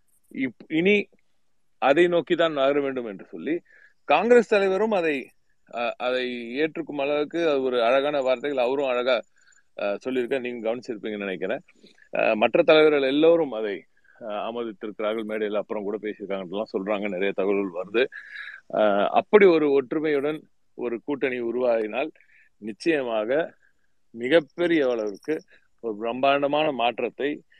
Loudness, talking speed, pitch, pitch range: -24 LUFS, 105 wpm, 135 Hz, 115-165 Hz